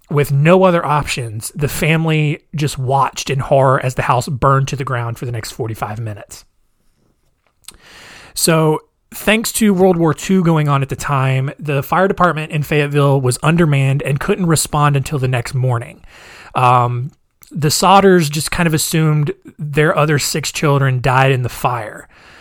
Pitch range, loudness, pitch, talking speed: 135-160 Hz, -15 LUFS, 145 Hz, 165 wpm